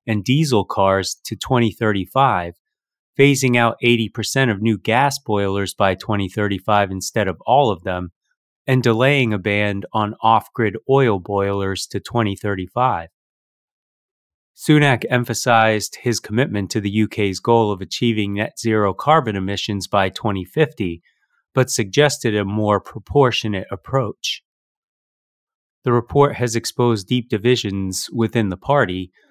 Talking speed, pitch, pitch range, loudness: 125 wpm, 110 Hz, 100-125 Hz, -19 LUFS